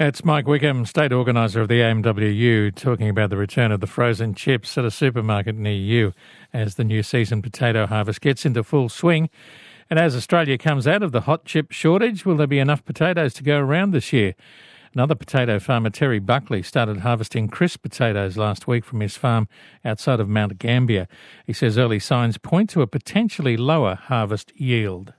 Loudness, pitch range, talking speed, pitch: -20 LUFS, 110-145 Hz, 190 wpm, 120 Hz